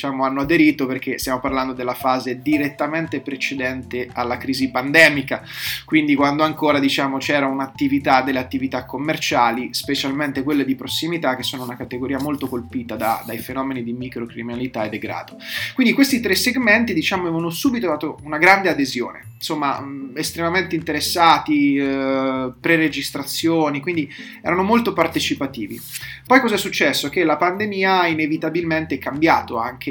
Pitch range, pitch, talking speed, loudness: 130-160 Hz, 140 Hz, 140 wpm, -19 LUFS